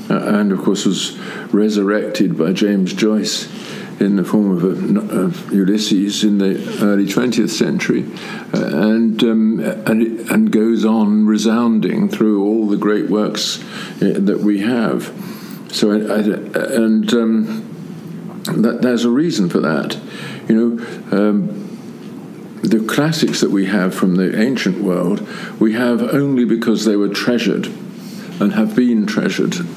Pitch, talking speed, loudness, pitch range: 110 Hz, 145 wpm, -16 LUFS, 105-125 Hz